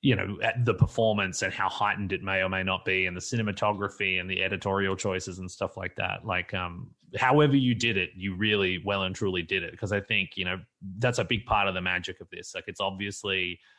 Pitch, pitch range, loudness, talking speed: 95 Hz, 95-105 Hz, -28 LUFS, 240 wpm